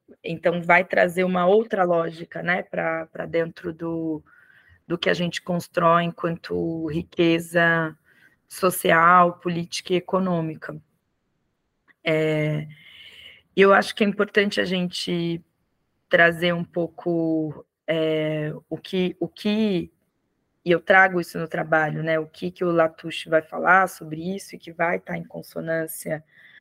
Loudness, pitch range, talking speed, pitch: -22 LUFS, 160-180 Hz, 135 wpm, 170 Hz